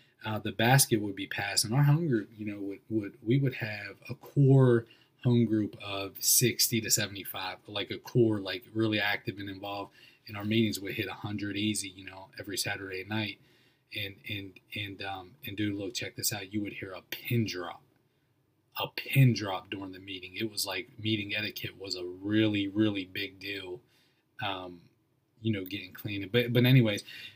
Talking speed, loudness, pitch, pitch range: 195 wpm, -30 LUFS, 105 Hz, 100-120 Hz